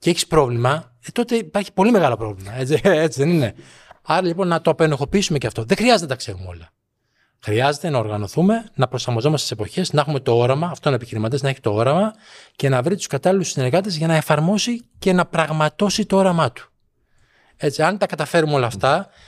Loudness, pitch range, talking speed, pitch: -19 LUFS, 125-185 Hz, 200 wpm, 155 Hz